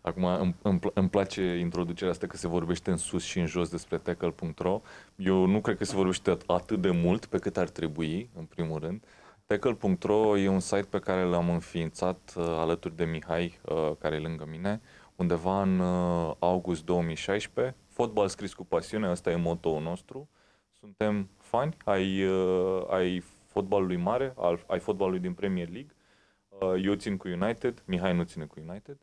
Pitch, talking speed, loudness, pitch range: 90 Hz, 175 wpm, -30 LUFS, 85-100 Hz